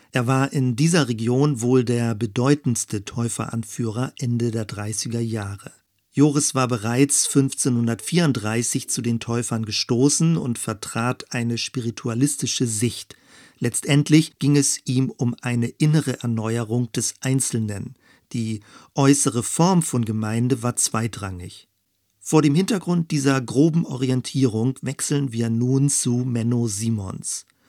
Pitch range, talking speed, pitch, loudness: 115-140 Hz, 120 wpm, 125 Hz, -22 LUFS